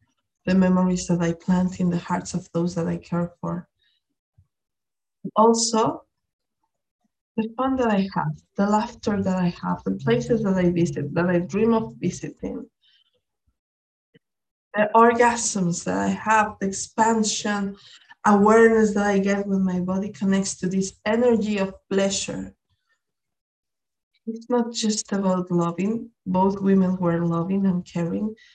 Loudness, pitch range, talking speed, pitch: -22 LUFS, 180-220 Hz, 140 wpm, 195 Hz